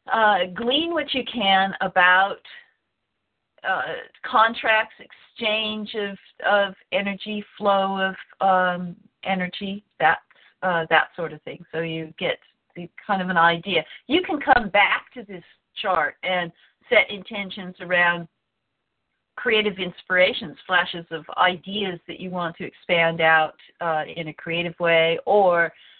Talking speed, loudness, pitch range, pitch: 135 wpm, -22 LUFS, 170-210 Hz, 185 Hz